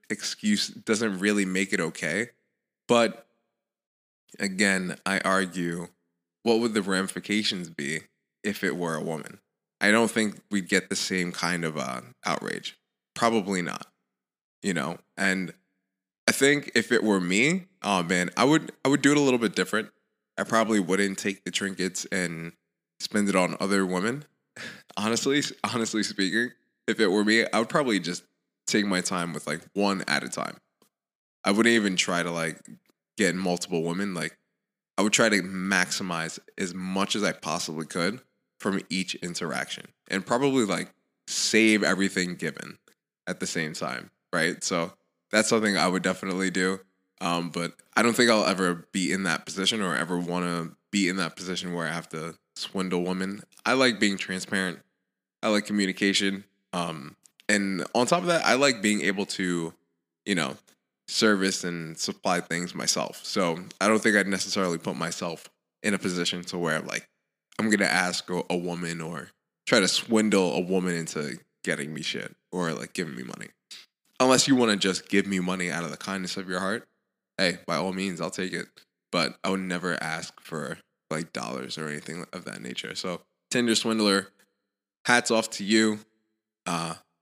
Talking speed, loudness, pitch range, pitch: 175 wpm, -26 LUFS, 90-110 Hz, 95 Hz